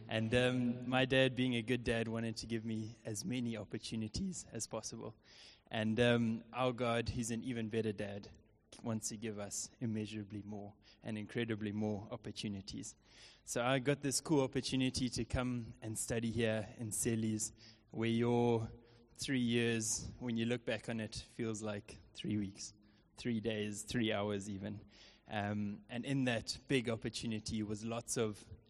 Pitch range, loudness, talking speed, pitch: 105-120 Hz, -38 LUFS, 160 wpm, 115 Hz